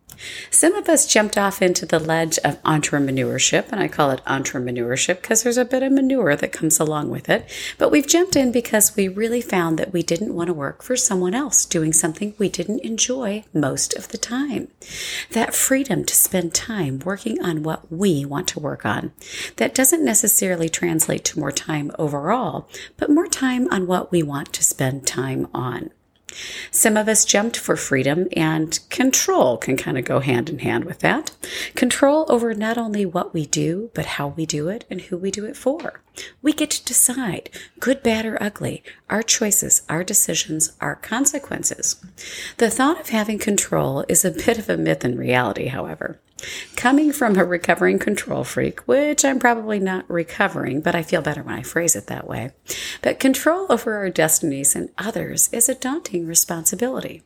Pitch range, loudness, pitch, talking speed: 165-250 Hz, -19 LUFS, 195 Hz, 190 wpm